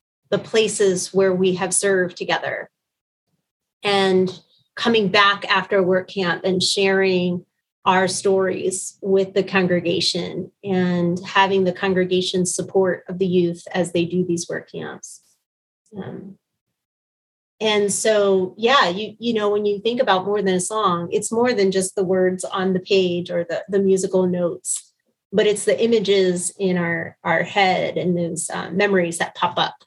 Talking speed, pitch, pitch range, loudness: 160 wpm, 190 Hz, 180-200 Hz, -20 LUFS